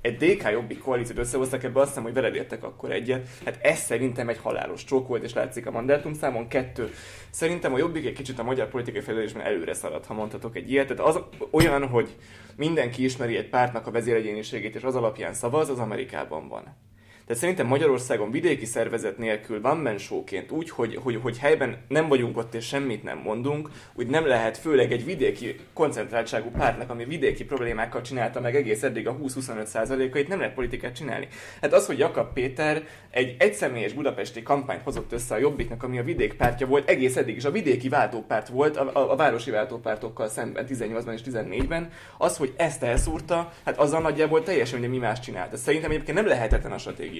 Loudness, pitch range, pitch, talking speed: -26 LUFS, 115-140 Hz, 125 Hz, 190 wpm